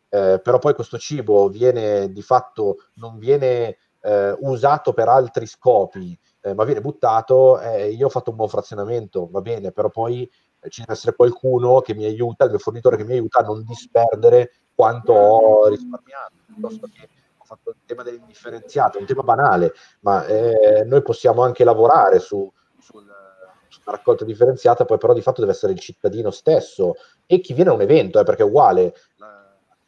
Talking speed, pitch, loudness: 180 wpm, 140 Hz, -17 LUFS